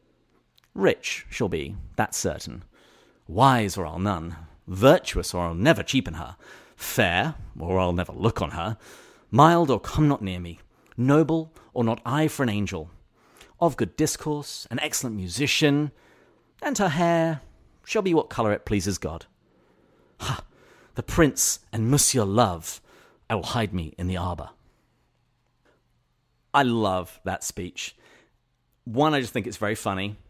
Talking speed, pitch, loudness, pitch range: 150 wpm, 115 Hz, -24 LUFS, 90-145 Hz